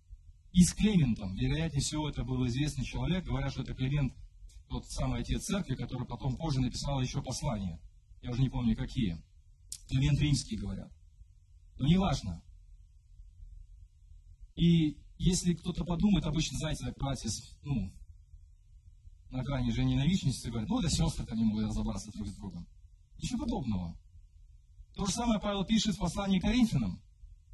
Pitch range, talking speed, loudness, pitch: 85-145 Hz, 150 wpm, -32 LUFS, 120 Hz